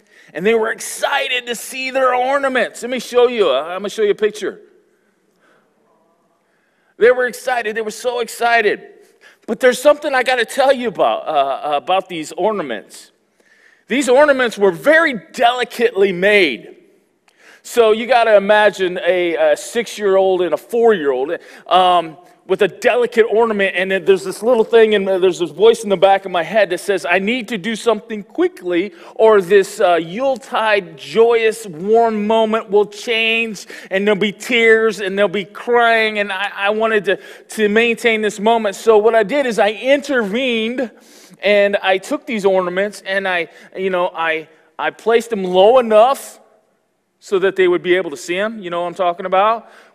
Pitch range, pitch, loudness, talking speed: 195-245 Hz, 220 Hz, -15 LUFS, 180 wpm